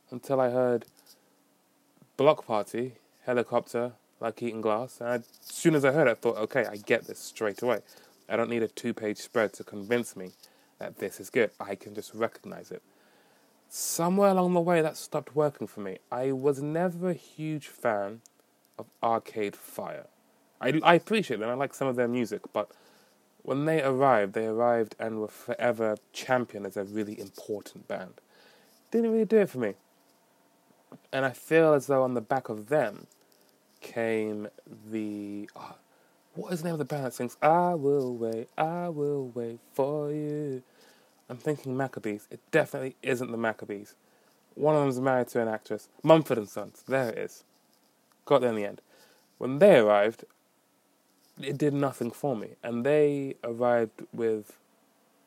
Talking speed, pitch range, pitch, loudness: 175 wpm, 110-145 Hz, 125 Hz, -29 LUFS